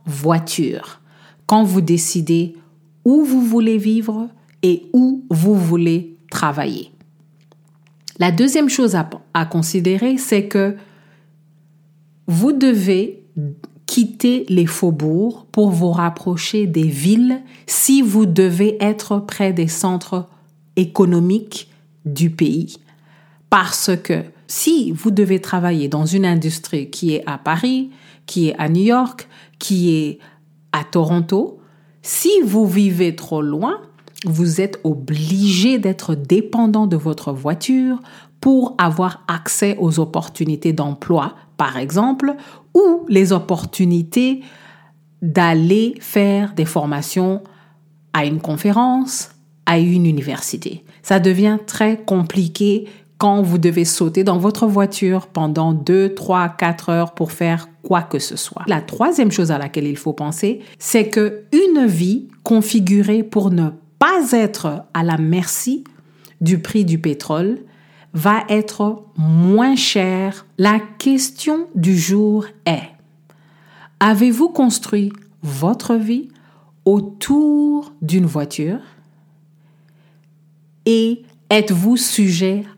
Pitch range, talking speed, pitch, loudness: 160-215 Hz, 115 wpm, 185 Hz, -17 LUFS